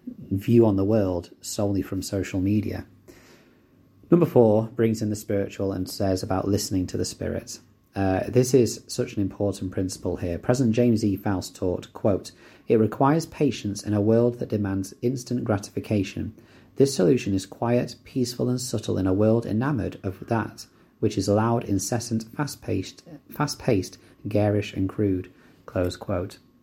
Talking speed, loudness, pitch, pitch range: 160 wpm, -25 LUFS, 105 Hz, 95-120 Hz